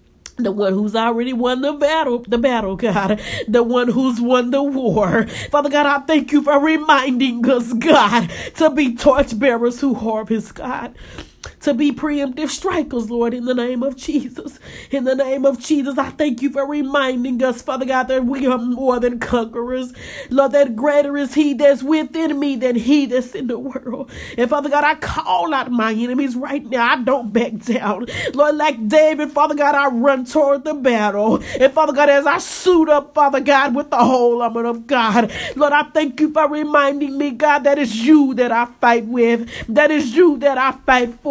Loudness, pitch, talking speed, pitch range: -17 LUFS, 270 Hz, 195 wpm, 240-290 Hz